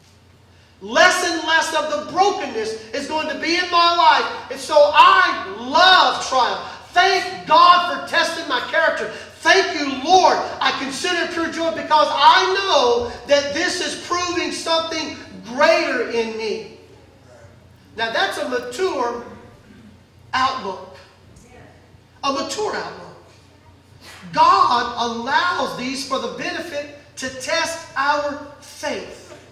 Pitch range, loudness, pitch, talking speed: 265-345 Hz, -18 LUFS, 310 Hz, 125 wpm